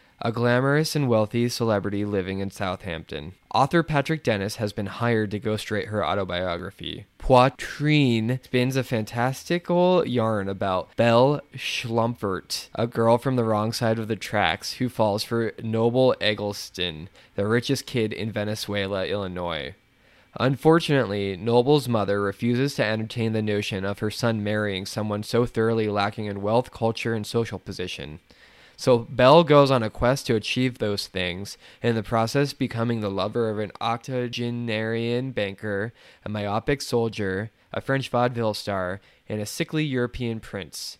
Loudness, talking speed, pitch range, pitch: -24 LUFS, 150 wpm, 105-125 Hz, 115 Hz